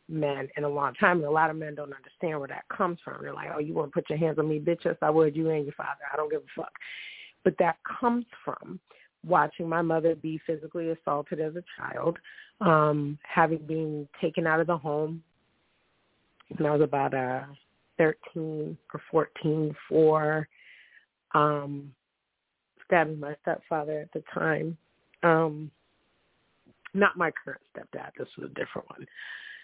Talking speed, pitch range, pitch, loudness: 170 wpm, 150-165 Hz, 155 Hz, -28 LUFS